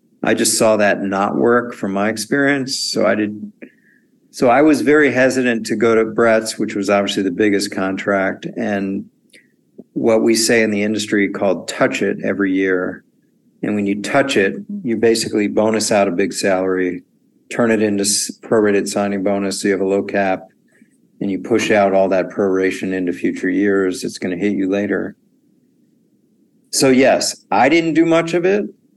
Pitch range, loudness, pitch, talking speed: 100-130 Hz, -16 LUFS, 110 Hz, 180 wpm